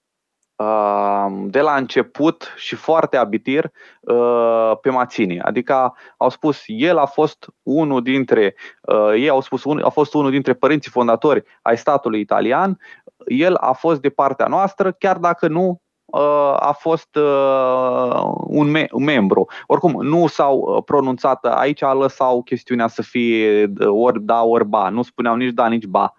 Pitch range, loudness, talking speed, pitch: 115-150 Hz, -17 LUFS, 135 wpm, 130 Hz